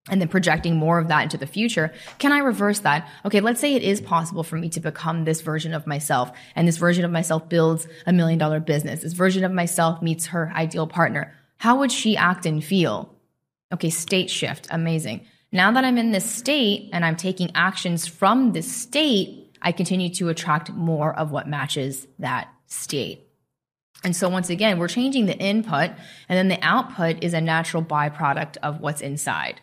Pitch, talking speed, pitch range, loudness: 170 Hz, 195 wpm, 155-190 Hz, -22 LUFS